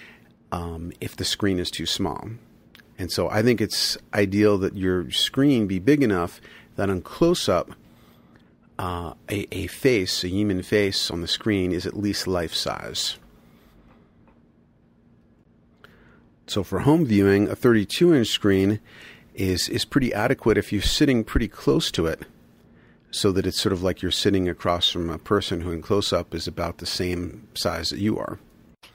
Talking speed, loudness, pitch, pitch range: 160 wpm, -23 LUFS, 95 Hz, 90-105 Hz